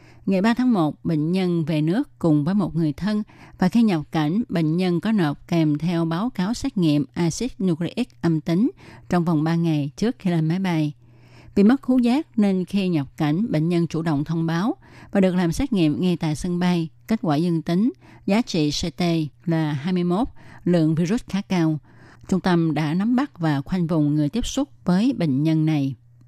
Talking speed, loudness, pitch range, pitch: 210 wpm, -22 LUFS, 155-195 Hz, 170 Hz